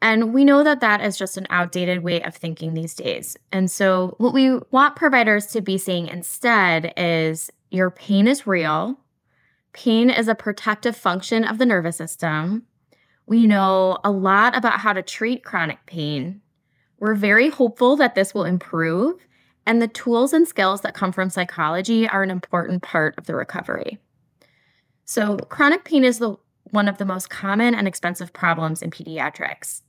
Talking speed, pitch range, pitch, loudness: 175 wpm, 180-230 Hz, 200 Hz, -20 LUFS